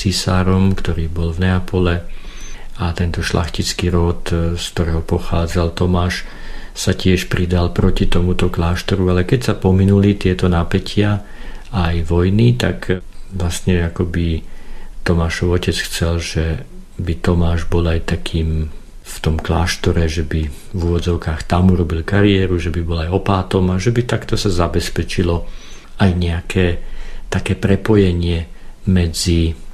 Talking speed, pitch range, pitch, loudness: 135 wpm, 85-95 Hz, 90 Hz, -17 LUFS